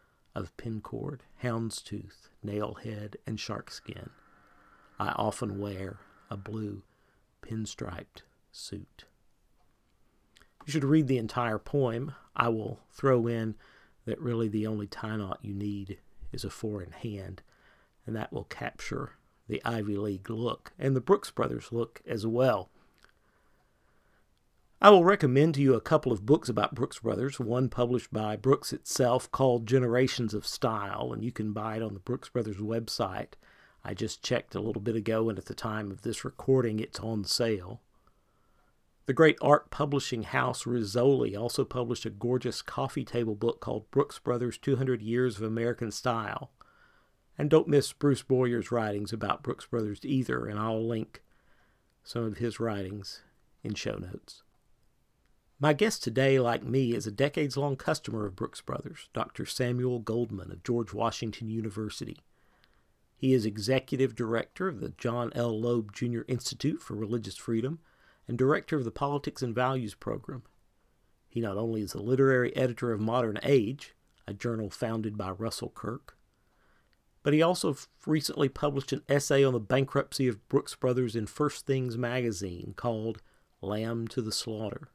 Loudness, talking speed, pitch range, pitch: -30 LUFS, 160 wpm, 110-130 Hz, 120 Hz